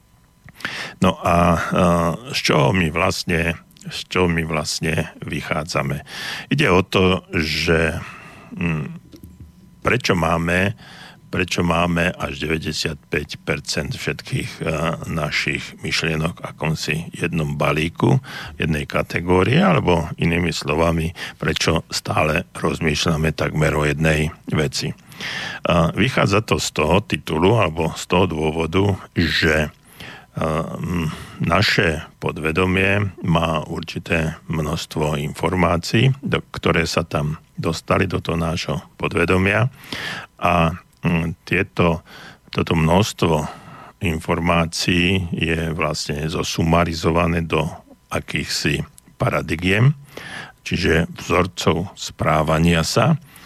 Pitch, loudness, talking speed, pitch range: 85 Hz, -20 LUFS, 95 wpm, 80-90 Hz